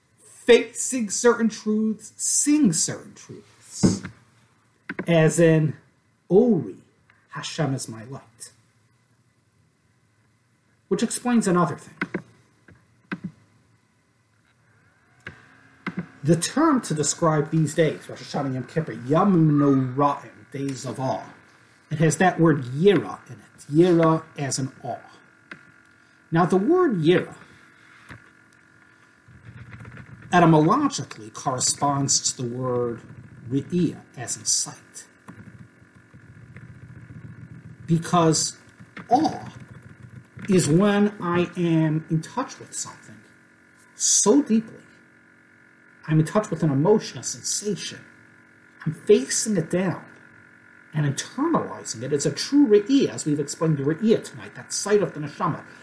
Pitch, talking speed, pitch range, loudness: 145 Hz, 105 wpm, 125-175 Hz, -22 LUFS